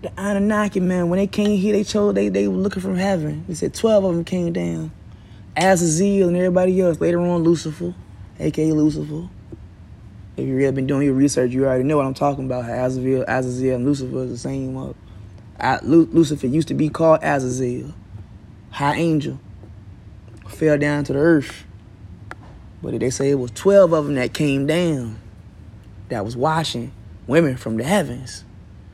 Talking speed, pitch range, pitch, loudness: 170 wpm, 100-165 Hz, 130 Hz, -19 LUFS